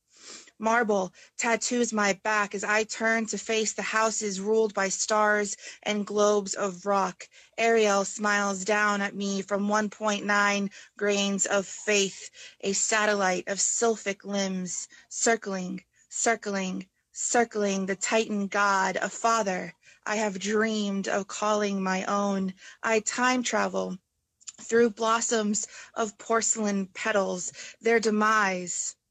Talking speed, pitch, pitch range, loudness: 120 wpm, 205 Hz, 195-220 Hz, -26 LUFS